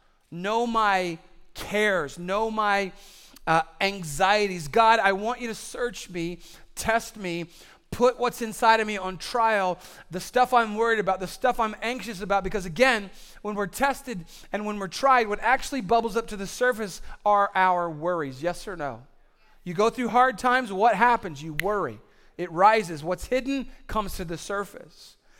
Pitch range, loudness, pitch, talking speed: 180-230 Hz, -25 LUFS, 205 Hz, 170 wpm